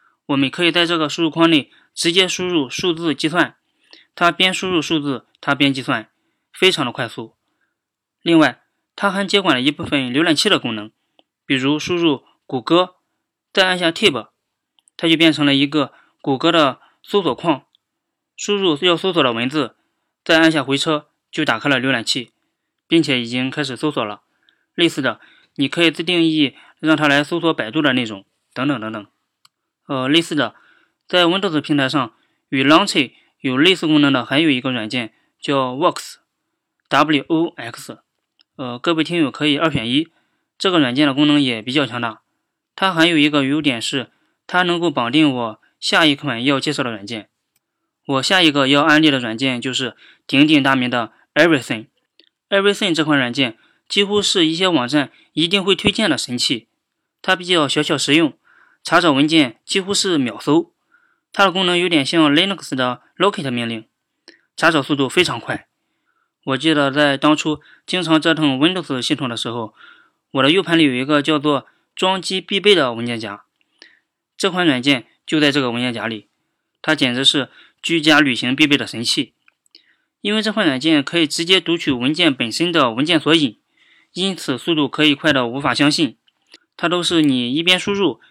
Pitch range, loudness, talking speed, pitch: 135-180 Hz, -17 LUFS, 285 characters per minute, 155 Hz